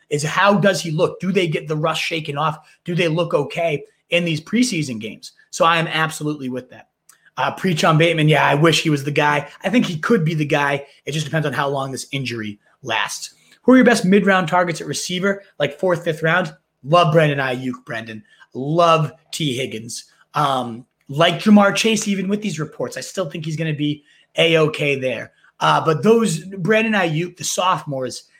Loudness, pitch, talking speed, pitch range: -18 LUFS, 160 Hz, 205 wpm, 145-180 Hz